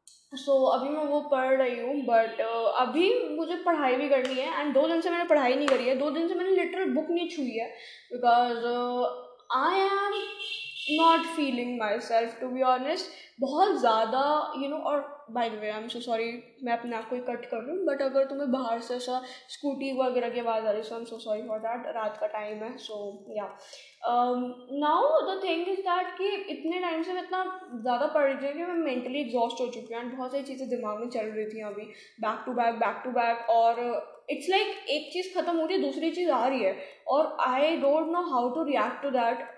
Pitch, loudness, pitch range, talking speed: 265 Hz, -28 LUFS, 235-320 Hz, 220 wpm